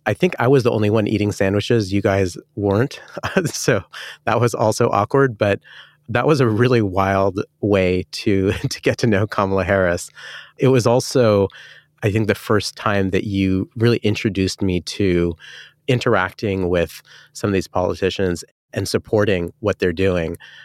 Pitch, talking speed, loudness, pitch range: 105 Hz, 165 wpm, -19 LUFS, 95-120 Hz